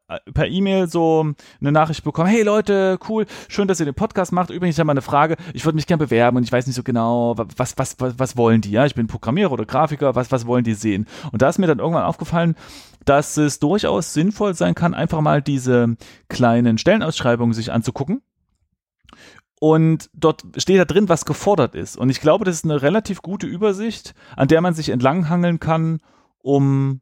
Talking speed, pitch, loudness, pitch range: 210 wpm, 150 Hz, -19 LUFS, 130-175 Hz